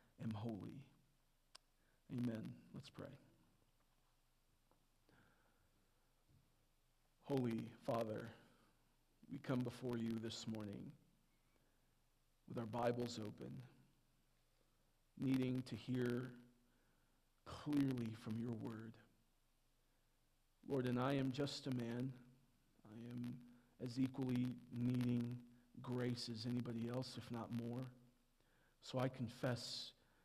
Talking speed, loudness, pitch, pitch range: 90 wpm, -46 LUFS, 120 Hz, 115-130 Hz